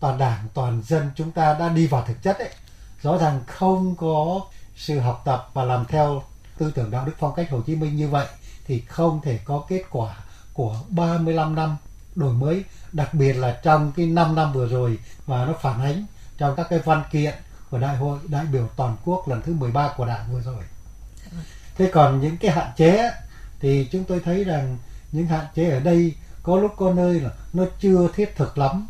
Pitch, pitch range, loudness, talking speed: 150 Hz, 125-170 Hz, -22 LUFS, 210 wpm